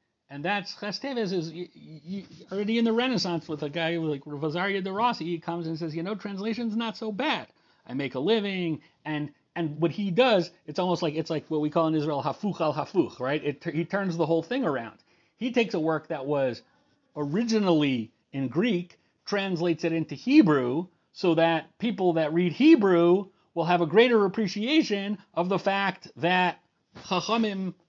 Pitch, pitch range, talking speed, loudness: 175 Hz, 160-205 Hz, 190 wpm, -27 LUFS